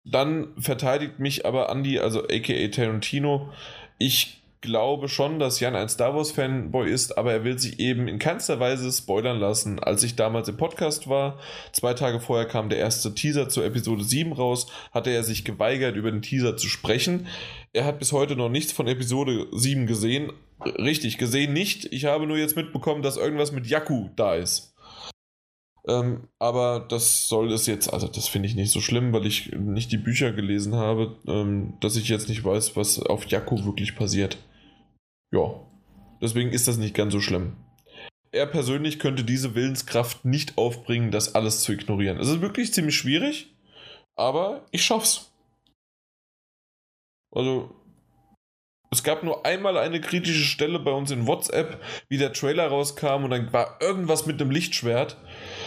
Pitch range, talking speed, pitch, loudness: 110-140 Hz, 170 wpm, 125 Hz, -25 LUFS